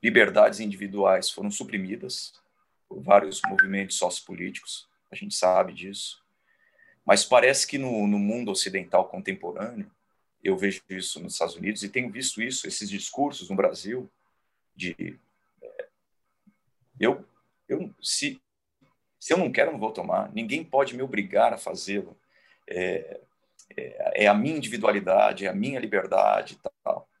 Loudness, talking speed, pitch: -26 LUFS, 140 wpm, 125 Hz